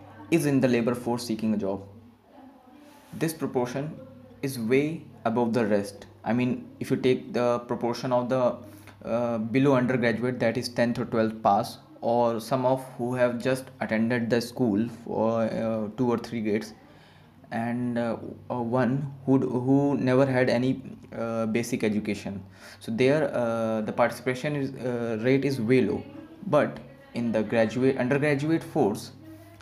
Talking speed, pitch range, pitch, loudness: 155 wpm, 115-130 Hz, 120 Hz, -27 LUFS